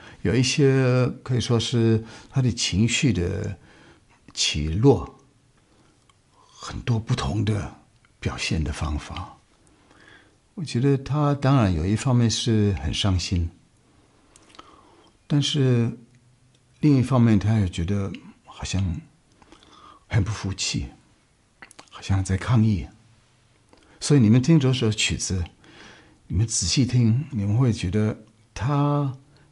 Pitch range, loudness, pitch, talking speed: 100-125 Hz, -23 LUFS, 110 Hz, 165 characters per minute